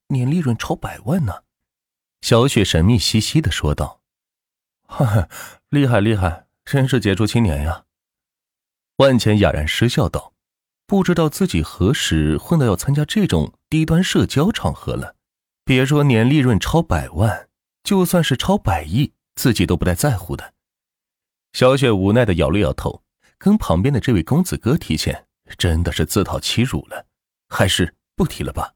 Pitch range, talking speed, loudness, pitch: 90-140 Hz, 240 characters per minute, -18 LUFS, 115 Hz